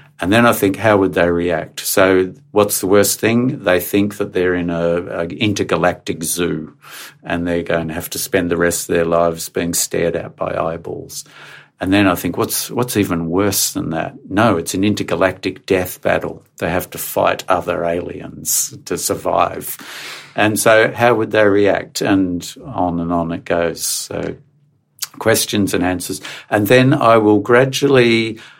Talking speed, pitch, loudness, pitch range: 175 wpm, 95 Hz, -16 LUFS, 85-110 Hz